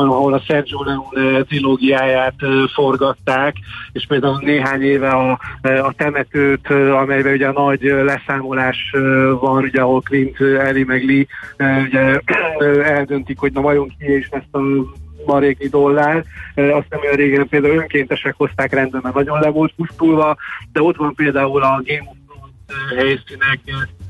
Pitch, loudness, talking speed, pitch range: 135 Hz, -15 LUFS, 145 wpm, 135-145 Hz